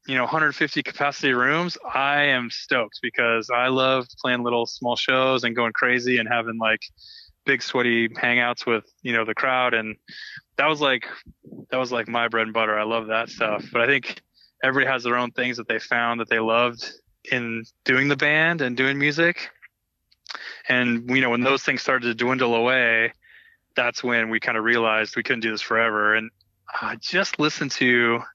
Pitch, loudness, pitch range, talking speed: 120 Hz, -22 LUFS, 115-130 Hz, 195 wpm